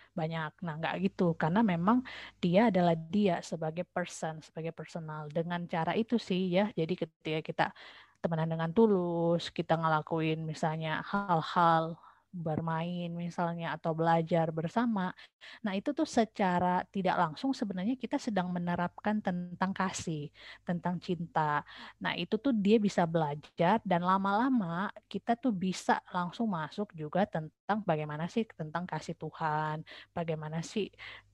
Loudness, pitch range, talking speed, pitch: -32 LUFS, 160-200 Hz, 130 wpm, 175 Hz